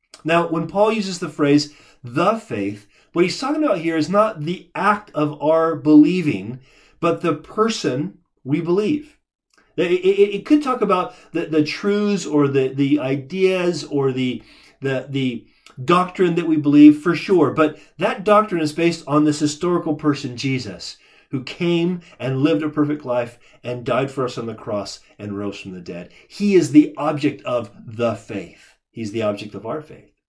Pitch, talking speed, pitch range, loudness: 155 Hz, 180 wpm, 135-175 Hz, -19 LUFS